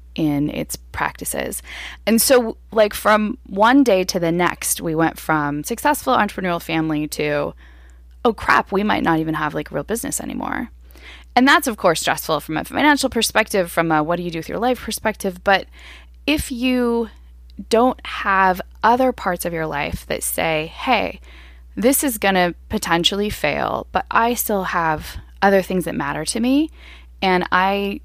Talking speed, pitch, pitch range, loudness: 170 wpm, 185 Hz, 155-220 Hz, -19 LUFS